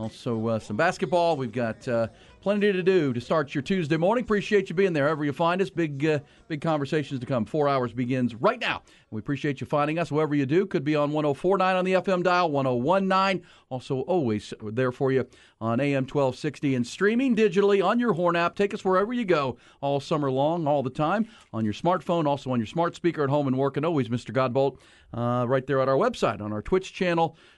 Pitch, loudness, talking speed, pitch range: 150 Hz, -25 LUFS, 225 wpm, 130-180 Hz